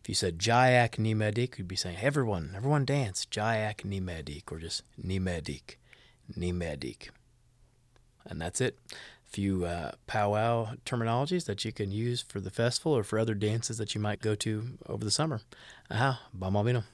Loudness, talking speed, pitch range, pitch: -31 LUFS, 165 wpm, 95-120 Hz, 110 Hz